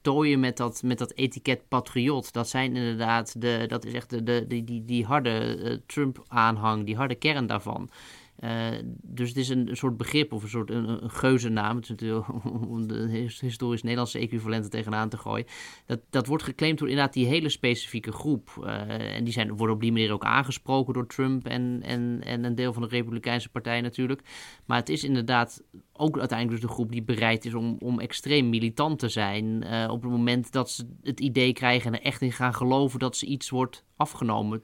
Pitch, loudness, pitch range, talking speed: 120 Hz, -28 LUFS, 115-130 Hz, 205 wpm